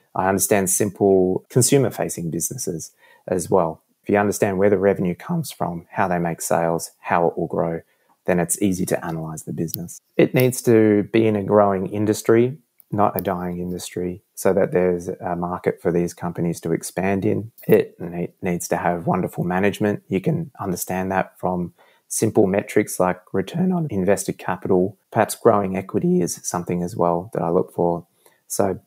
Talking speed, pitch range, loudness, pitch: 175 wpm, 90-105 Hz, -21 LUFS, 95 Hz